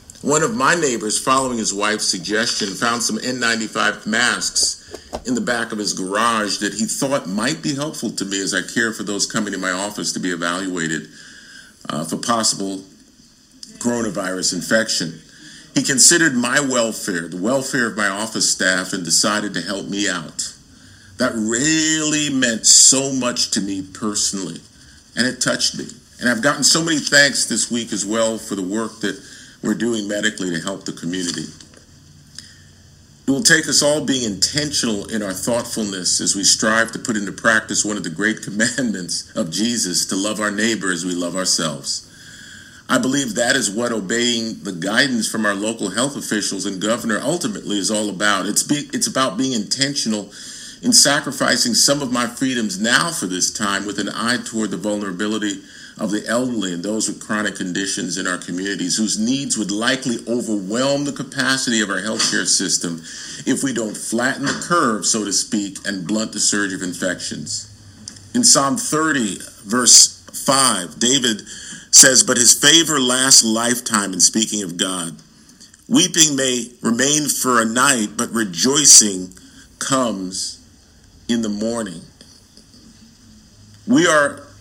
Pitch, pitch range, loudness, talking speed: 110 Hz, 100-125 Hz, -17 LUFS, 165 wpm